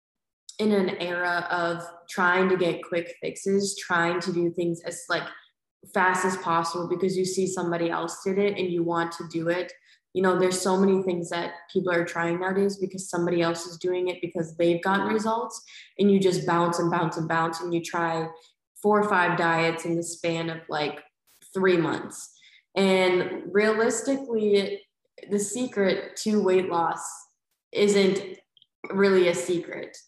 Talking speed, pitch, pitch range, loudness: 170 wpm, 180 Hz, 170-195 Hz, -25 LUFS